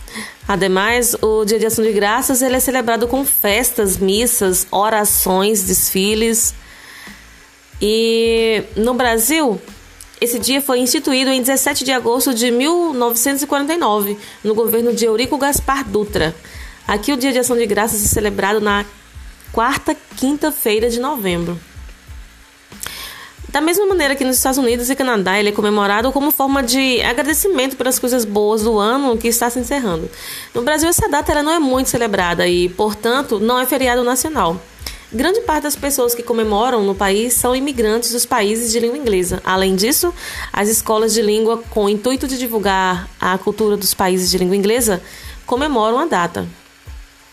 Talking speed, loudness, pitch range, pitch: 155 wpm, -16 LUFS, 210-265 Hz, 235 Hz